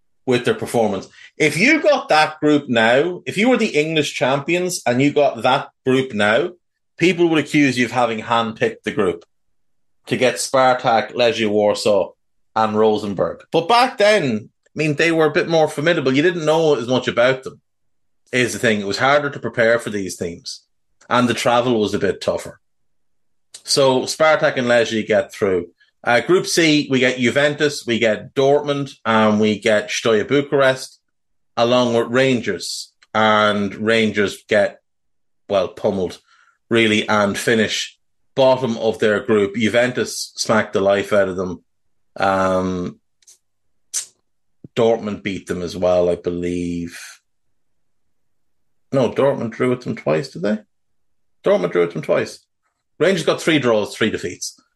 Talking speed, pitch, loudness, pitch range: 155 wpm, 120 Hz, -18 LUFS, 105-150 Hz